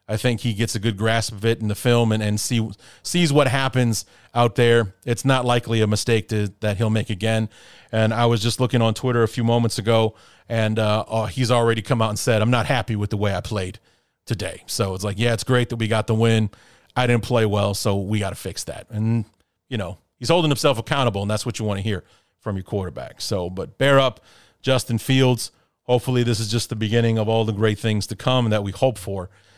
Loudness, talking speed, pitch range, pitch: -21 LUFS, 245 wpm, 105-120 Hz, 115 Hz